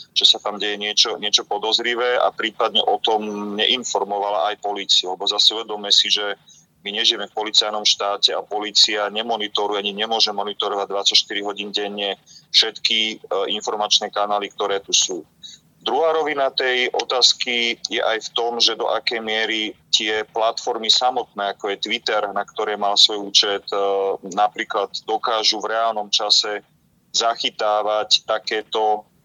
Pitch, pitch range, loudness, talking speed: 105 Hz, 100-110 Hz, -19 LUFS, 140 wpm